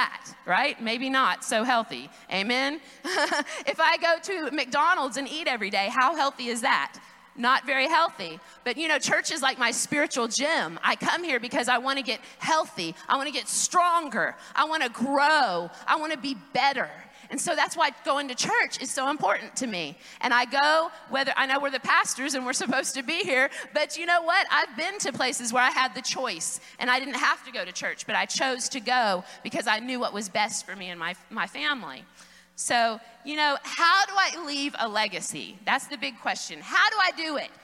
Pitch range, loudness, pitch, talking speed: 240-305 Hz, -25 LUFS, 270 Hz, 220 wpm